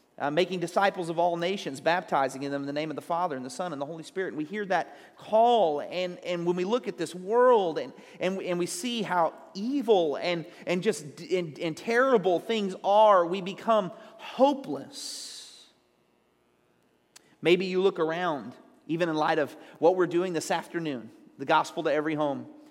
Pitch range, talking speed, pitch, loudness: 160-200 Hz, 180 wpm, 180 Hz, -27 LUFS